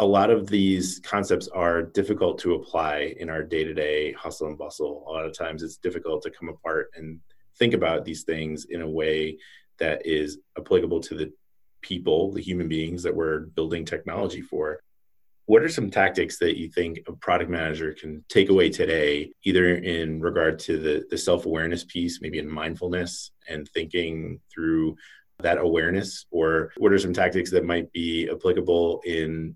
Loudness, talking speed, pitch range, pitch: -25 LUFS, 175 wpm, 80-90 Hz, 85 Hz